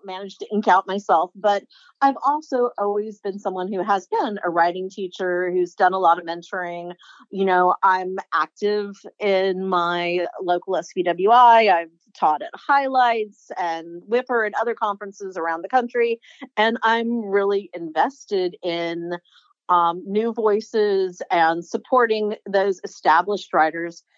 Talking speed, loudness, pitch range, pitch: 140 wpm, -21 LUFS, 175-220 Hz, 195 Hz